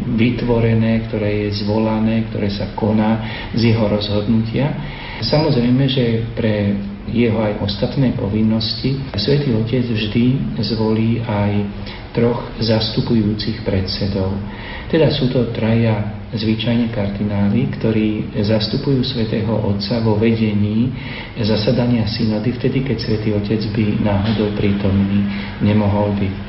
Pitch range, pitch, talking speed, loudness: 105-115 Hz, 110 Hz, 110 wpm, -18 LUFS